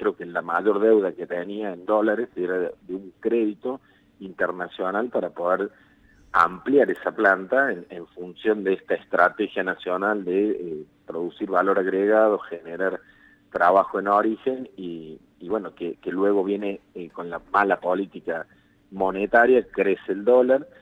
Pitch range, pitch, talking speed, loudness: 90-110 Hz, 100 Hz, 145 wpm, -23 LUFS